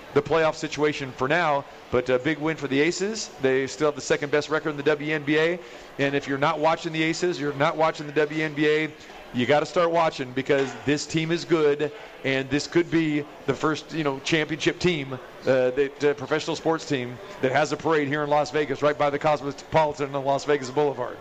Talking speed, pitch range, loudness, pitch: 215 wpm, 140-160 Hz, -24 LUFS, 150 Hz